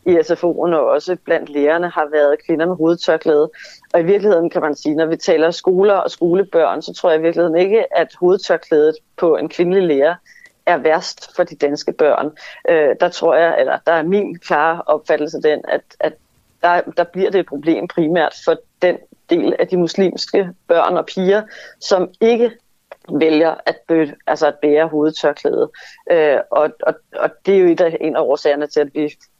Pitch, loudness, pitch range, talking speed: 170 Hz, -16 LUFS, 155-205 Hz, 195 wpm